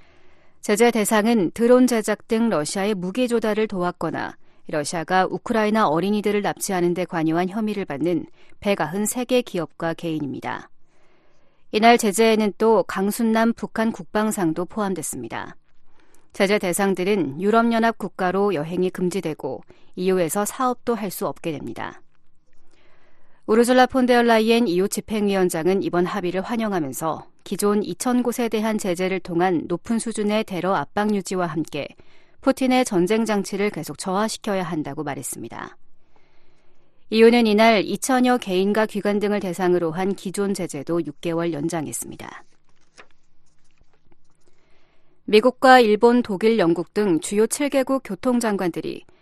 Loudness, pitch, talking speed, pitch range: -21 LUFS, 205 Hz, 300 characters per minute, 180-225 Hz